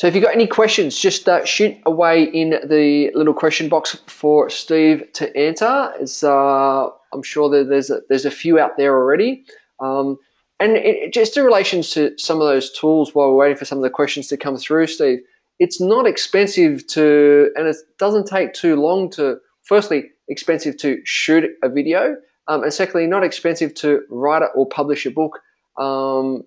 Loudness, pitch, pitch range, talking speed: -17 LUFS, 155 Hz, 145-195 Hz, 190 wpm